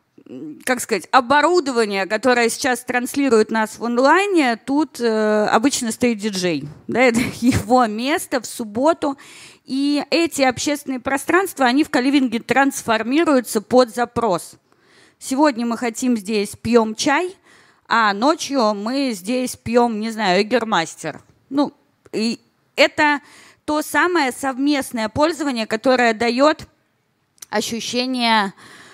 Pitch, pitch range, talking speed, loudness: 250 Hz, 225-285 Hz, 110 wpm, -18 LUFS